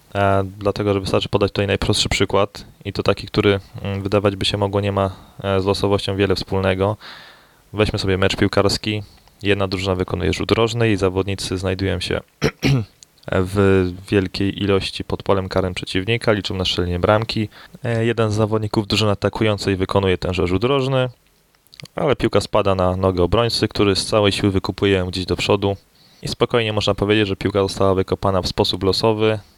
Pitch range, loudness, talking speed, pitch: 95-105 Hz, -19 LUFS, 160 wpm, 100 Hz